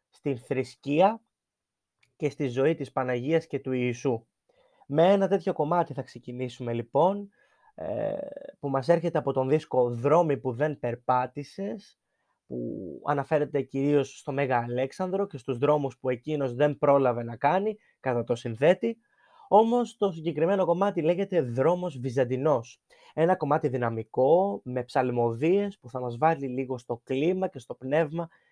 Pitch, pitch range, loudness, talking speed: 145 Hz, 130-180 Hz, -27 LUFS, 140 wpm